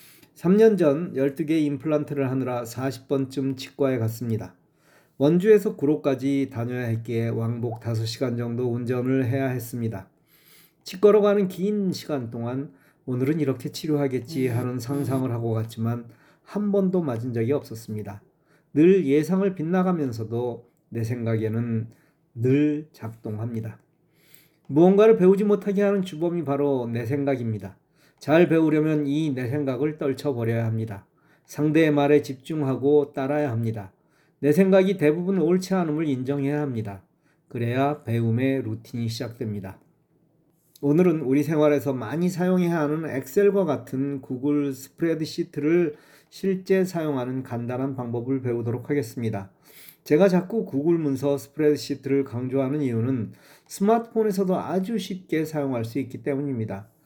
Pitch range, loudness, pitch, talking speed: 125-160 Hz, -24 LUFS, 140 Hz, 315 characters per minute